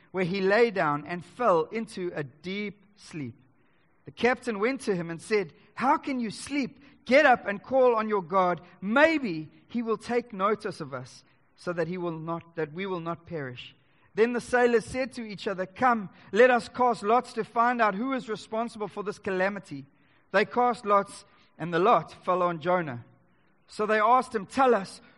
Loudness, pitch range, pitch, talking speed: -27 LUFS, 170-235 Hz, 200 Hz, 195 wpm